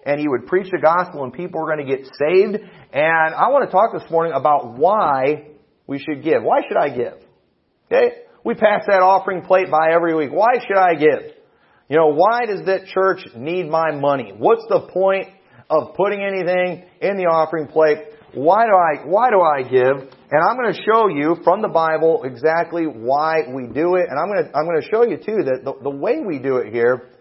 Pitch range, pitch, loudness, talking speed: 150-195 Hz, 165 Hz, -18 LUFS, 220 wpm